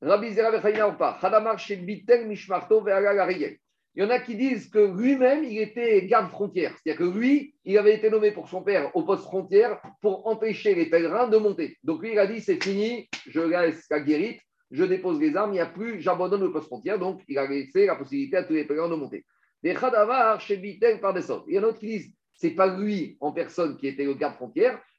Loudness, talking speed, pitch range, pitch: -25 LUFS, 210 wpm, 180-240 Hz, 210 Hz